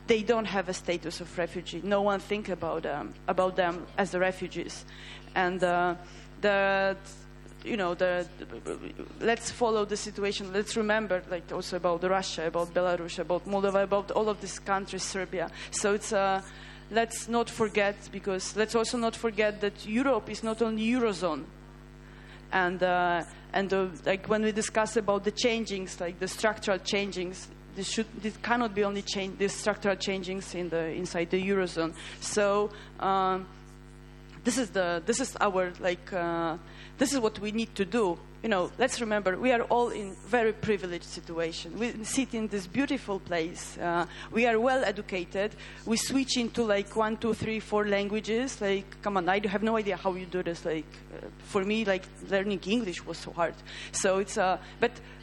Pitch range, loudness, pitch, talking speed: 180-215 Hz, -30 LUFS, 195 Hz, 180 wpm